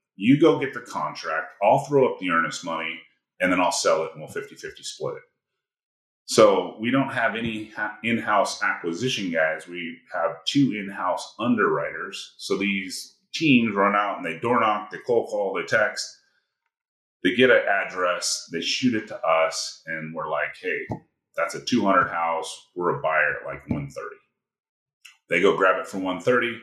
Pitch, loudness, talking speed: 115 Hz, -23 LUFS, 180 wpm